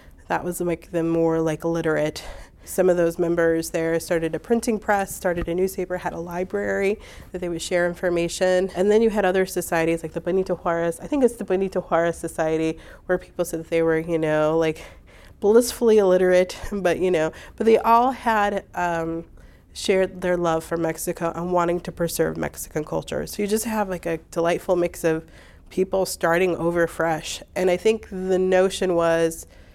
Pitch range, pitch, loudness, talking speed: 165-185 Hz, 175 Hz, -23 LUFS, 190 wpm